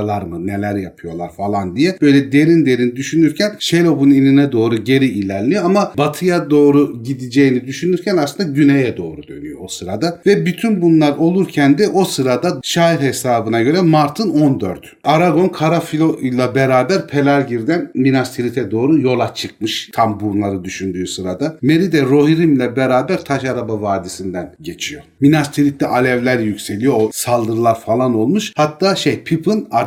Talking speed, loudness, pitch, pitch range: 140 wpm, -15 LUFS, 140 Hz, 115-160 Hz